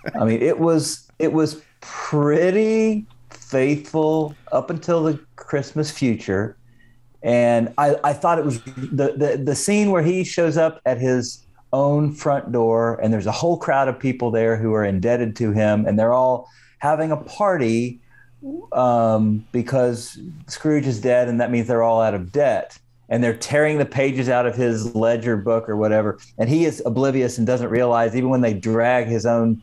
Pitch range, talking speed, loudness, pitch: 115-150 Hz, 180 wpm, -20 LUFS, 125 Hz